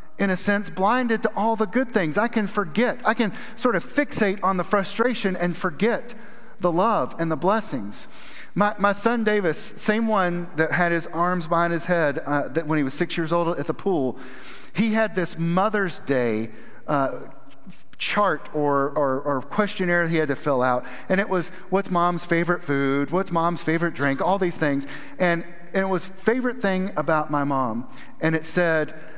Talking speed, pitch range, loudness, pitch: 190 wpm, 160-205 Hz, -23 LUFS, 175 Hz